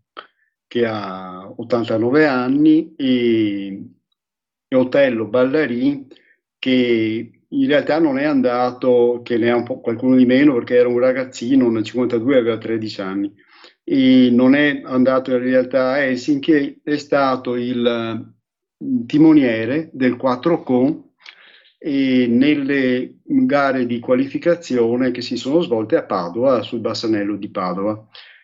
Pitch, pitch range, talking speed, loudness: 125 Hz, 120-150 Hz, 120 wpm, -17 LUFS